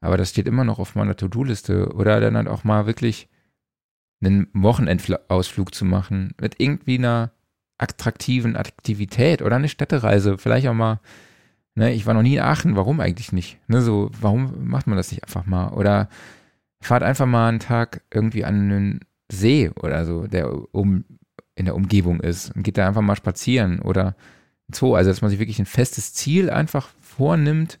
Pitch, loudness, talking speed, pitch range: 105 Hz, -21 LUFS, 180 wpm, 95-125 Hz